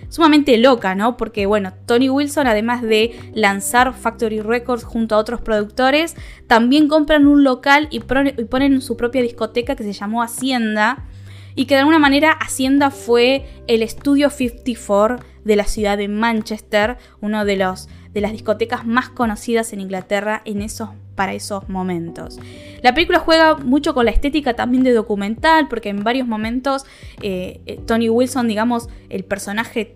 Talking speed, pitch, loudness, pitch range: 155 wpm, 230 Hz, -17 LUFS, 210-265 Hz